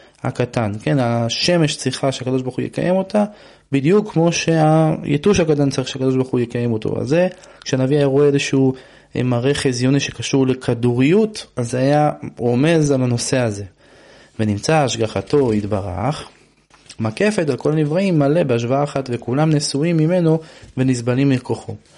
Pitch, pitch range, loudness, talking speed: 135 Hz, 120-155 Hz, -18 LUFS, 140 wpm